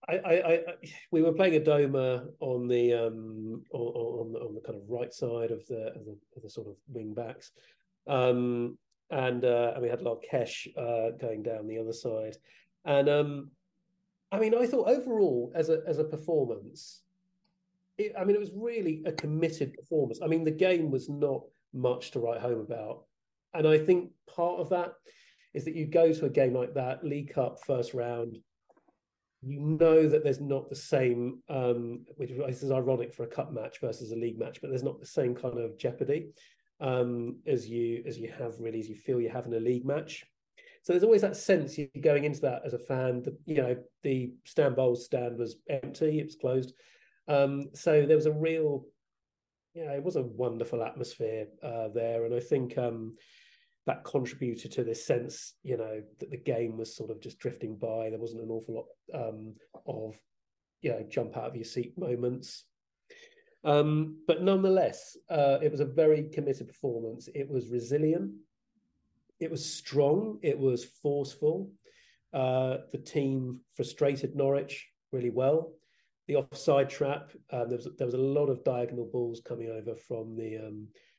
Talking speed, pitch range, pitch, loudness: 190 wpm, 120-160 Hz, 135 Hz, -31 LUFS